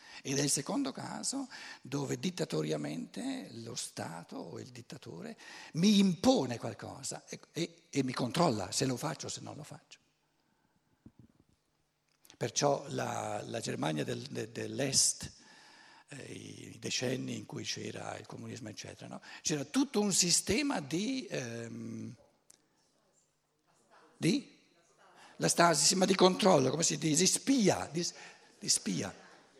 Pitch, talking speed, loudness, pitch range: 160 Hz, 130 wpm, -32 LUFS, 135-190 Hz